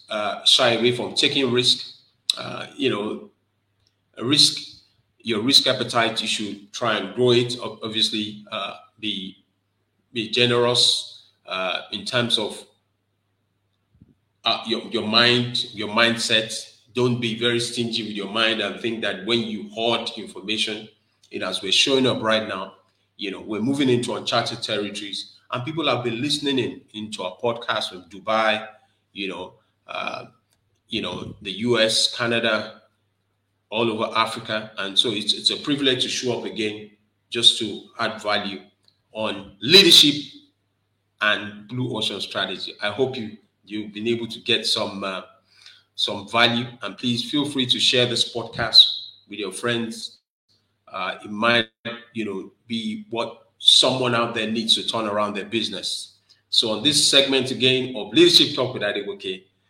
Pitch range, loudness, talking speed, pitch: 105-120 Hz, -20 LUFS, 155 wpm, 110 Hz